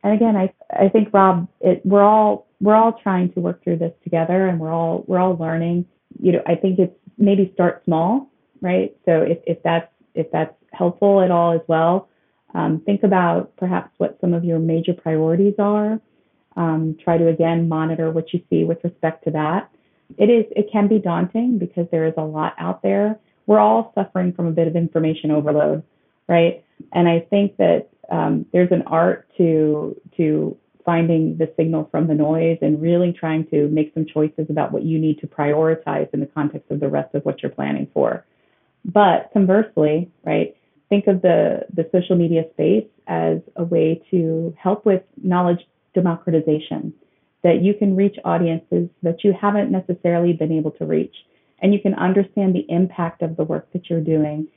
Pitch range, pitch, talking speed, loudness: 160-190 Hz, 170 Hz, 190 wpm, -19 LUFS